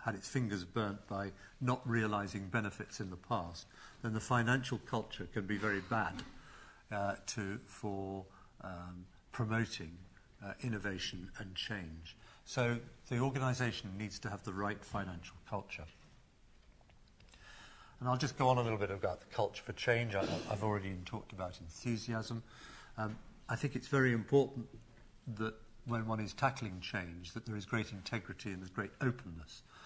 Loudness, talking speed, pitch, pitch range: -39 LUFS, 155 wpm, 110 Hz, 95-120 Hz